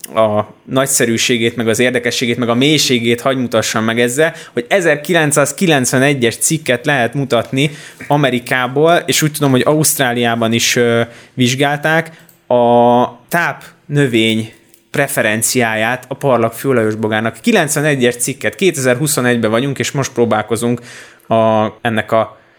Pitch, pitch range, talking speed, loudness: 125 Hz, 115-145 Hz, 115 wpm, -14 LUFS